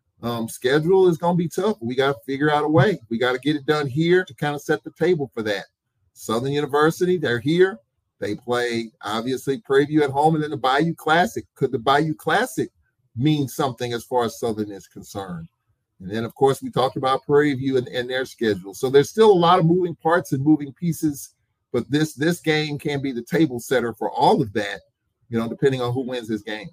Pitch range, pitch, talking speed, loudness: 115-155 Hz, 135 Hz, 230 wpm, -21 LUFS